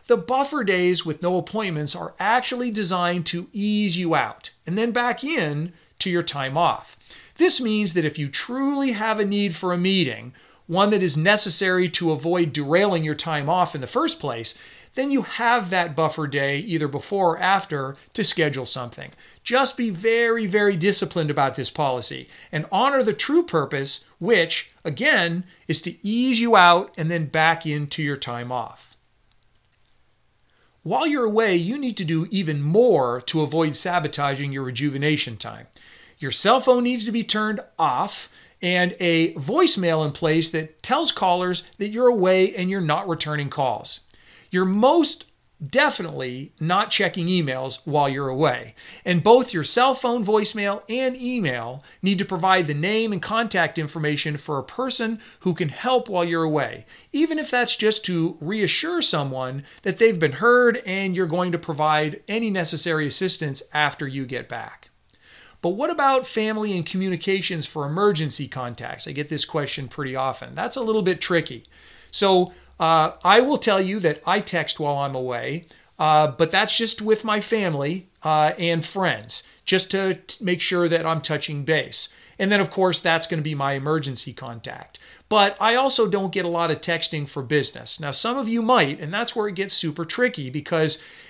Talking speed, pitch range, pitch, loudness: 175 wpm, 150-215 Hz, 175 Hz, -22 LUFS